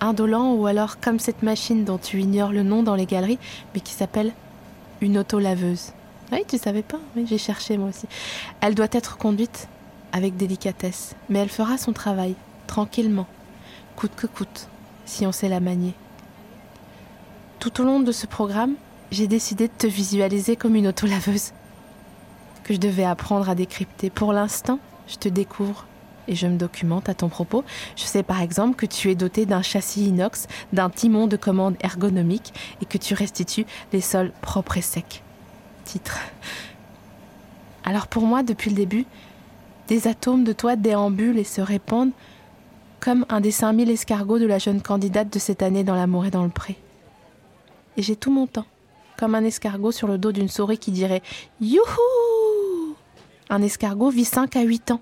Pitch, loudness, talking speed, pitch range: 210 Hz, -23 LUFS, 180 wpm, 195-225 Hz